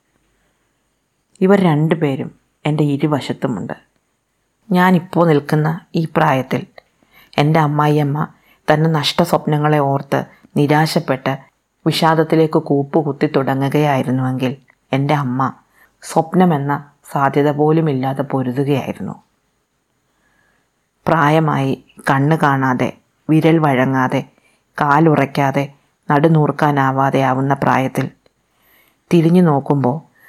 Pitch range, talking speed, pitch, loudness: 135-160 Hz, 70 wpm, 145 Hz, -16 LUFS